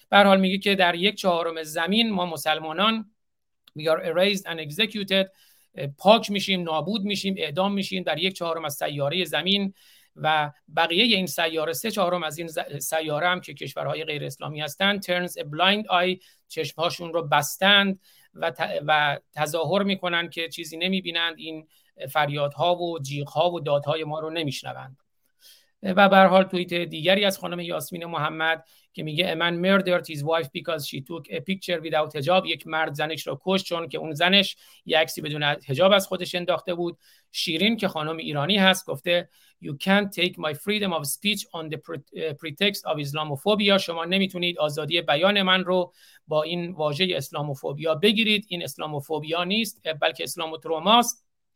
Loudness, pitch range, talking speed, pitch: -24 LUFS, 155-190 Hz, 160 wpm, 170 Hz